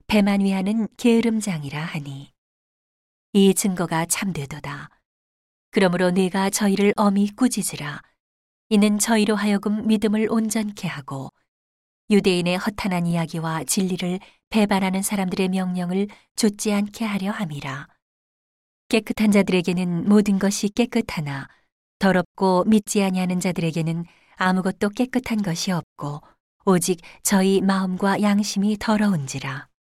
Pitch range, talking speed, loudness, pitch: 175-210 Hz, 285 characters per minute, -22 LUFS, 195 Hz